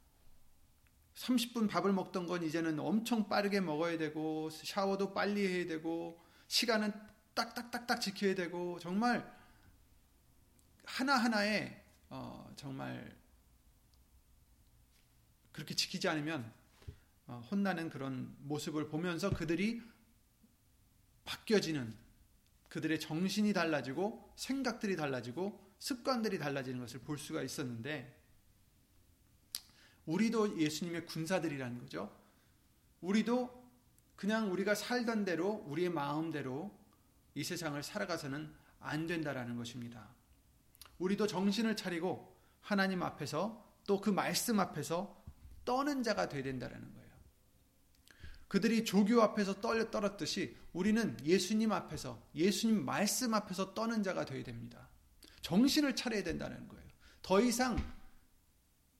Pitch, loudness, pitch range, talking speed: 175 Hz, -36 LUFS, 145-210 Hz, 260 characters per minute